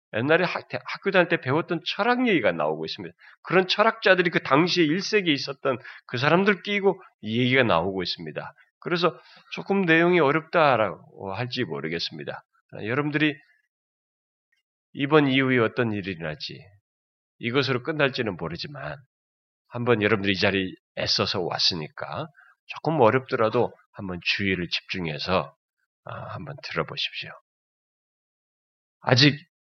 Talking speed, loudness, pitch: 305 characters per minute, -24 LUFS, 135 Hz